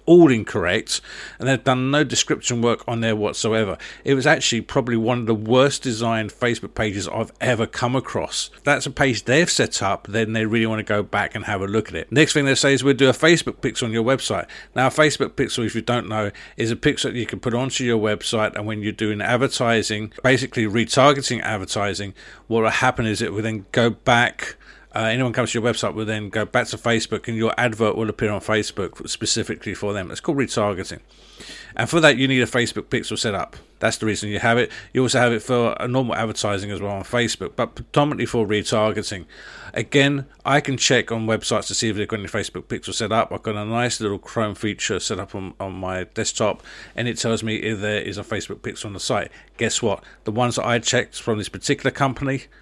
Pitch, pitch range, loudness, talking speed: 115 Hz, 105-125 Hz, -21 LUFS, 235 wpm